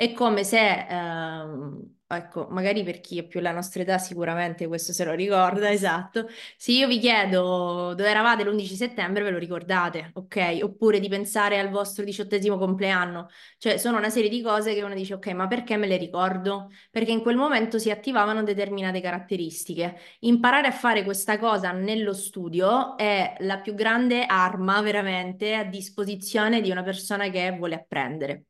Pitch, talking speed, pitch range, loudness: 200 Hz, 175 wpm, 180-215 Hz, -25 LUFS